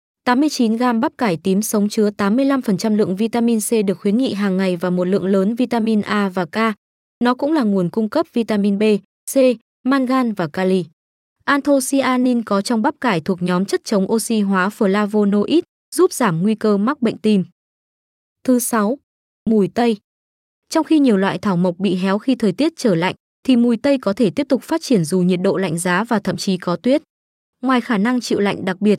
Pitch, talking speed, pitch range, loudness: 215 Hz, 200 wpm, 195-250 Hz, -18 LUFS